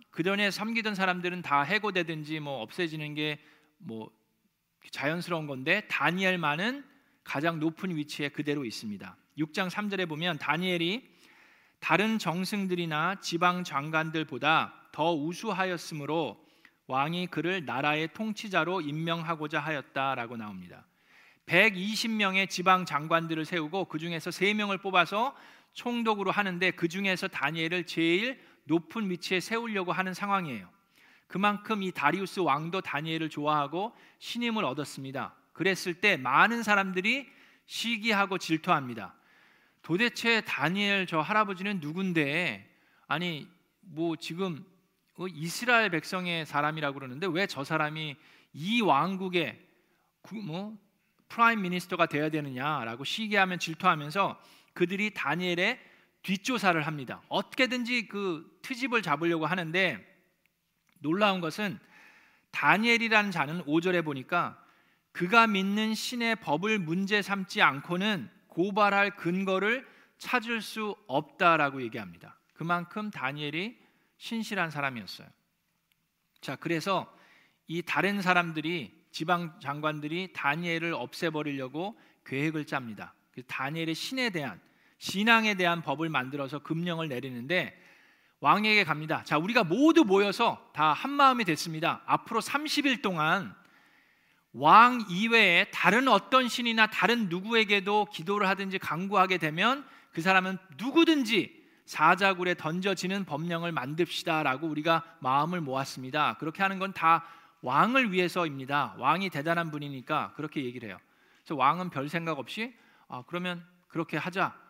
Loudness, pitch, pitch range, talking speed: -28 LUFS, 180 Hz, 155-200 Hz, 300 characters per minute